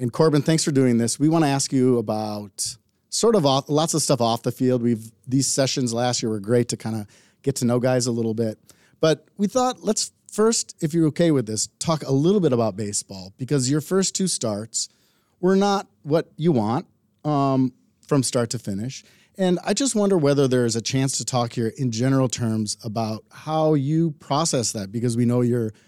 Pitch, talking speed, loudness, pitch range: 130 Hz, 215 wpm, -22 LUFS, 115-160 Hz